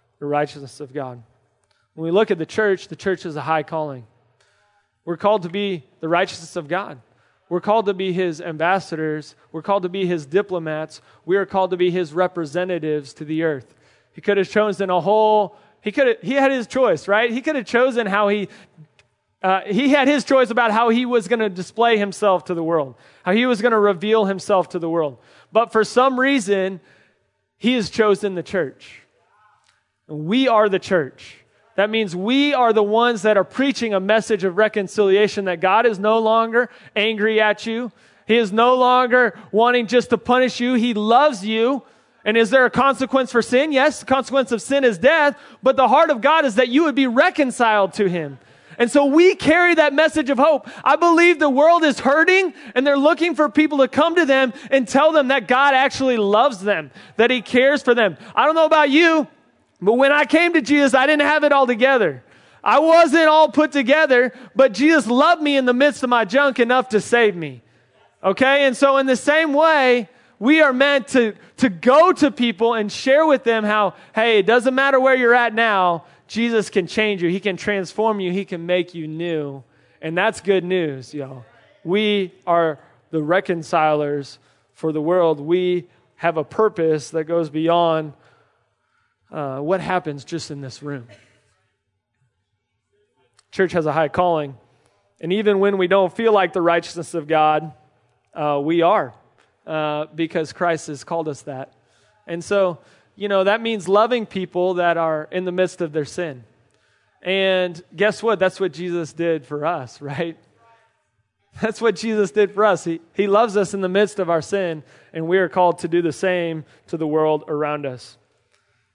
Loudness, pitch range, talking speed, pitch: -18 LUFS, 165-250 Hz, 195 wpm, 205 Hz